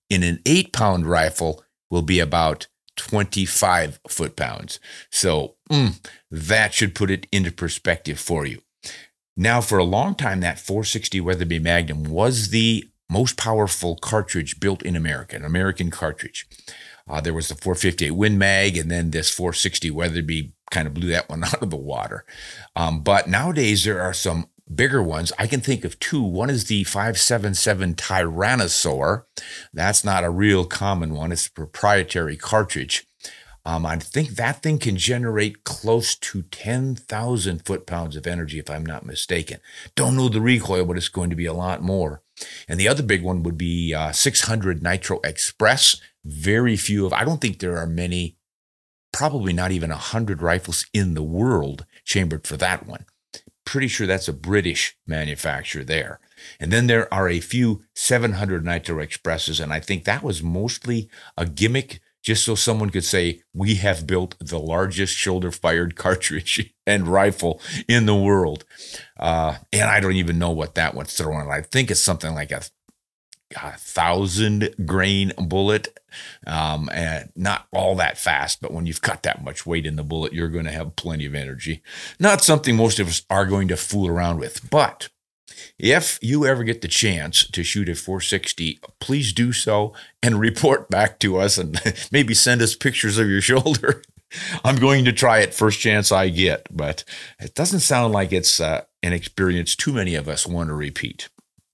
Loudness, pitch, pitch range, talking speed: -21 LUFS, 95 Hz, 85-110 Hz, 175 wpm